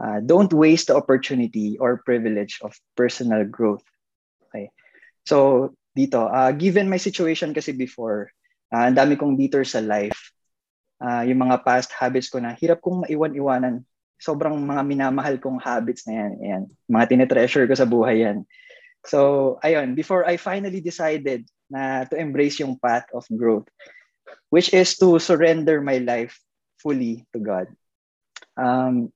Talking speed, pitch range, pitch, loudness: 150 wpm, 120-160 Hz, 135 Hz, -21 LUFS